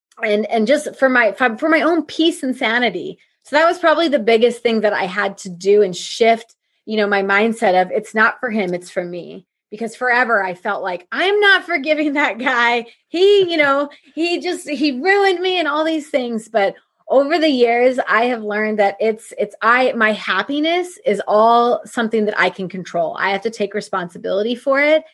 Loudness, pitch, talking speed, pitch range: -17 LUFS, 235 Hz, 210 wpm, 210-300 Hz